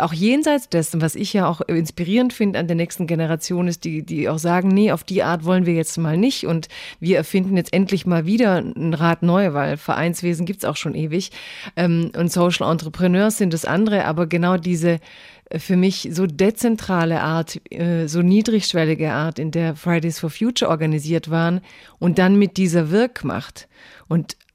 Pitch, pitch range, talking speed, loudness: 175 Hz, 165-190 Hz, 180 wpm, -19 LUFS